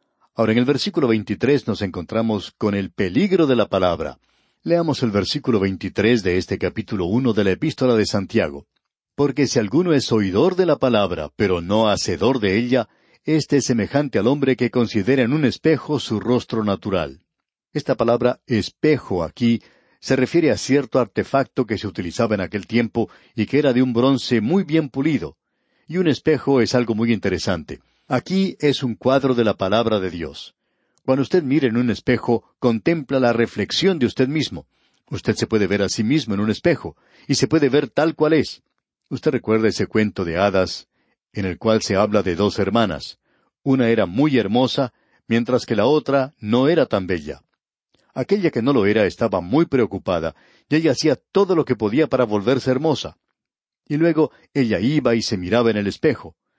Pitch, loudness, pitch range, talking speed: 120 Hz, -20 LUFS, 105-140 Hz, 185 wpm